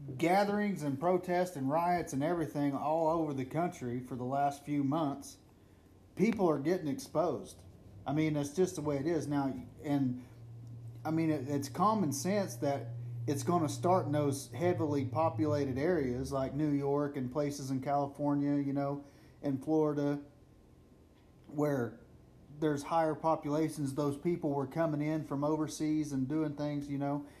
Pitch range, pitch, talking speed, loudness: 135-155 Hz, 145 Hz, 160 wpm, -34 LUFS